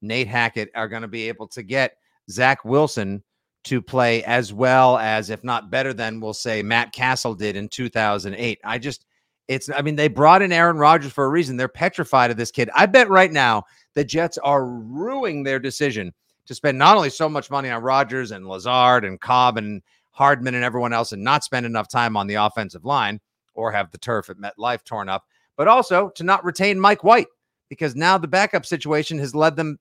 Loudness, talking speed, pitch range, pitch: -19 LUFS, 210 wpm, 115-150 Hz, 125 Hz